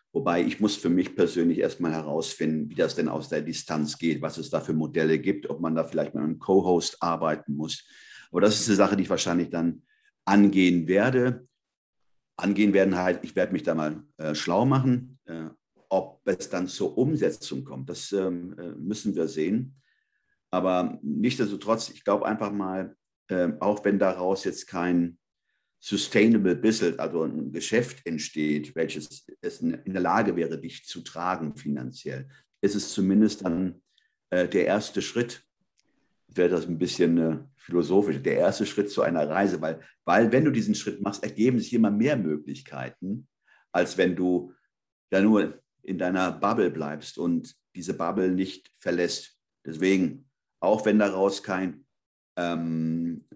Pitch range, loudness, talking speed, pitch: 80-100 Hz, -26 LUFS, 160 wpm, 90 Hz